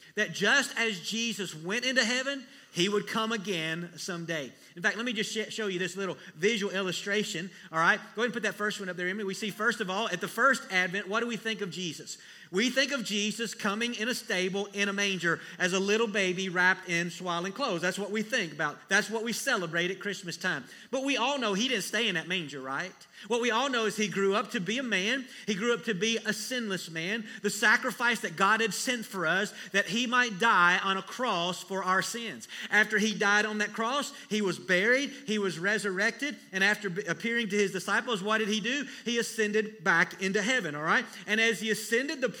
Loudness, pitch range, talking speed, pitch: -29 LUFS, 190-230 Hz, 235 wpm, 210 Hz